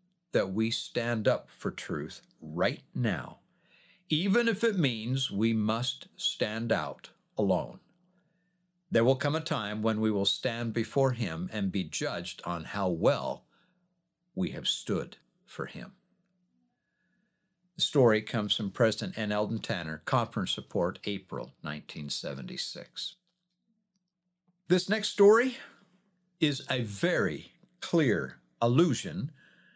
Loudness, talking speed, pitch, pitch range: -30 LUFS, 120 wpm, 165 Hz, 110-185 Hz